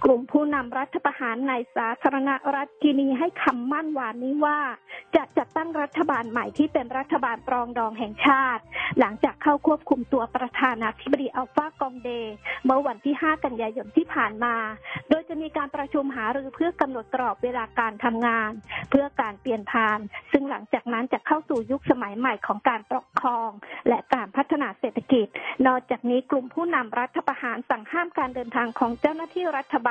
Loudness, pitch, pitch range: -25 LUFS, 265 Hz, 240-295 Hz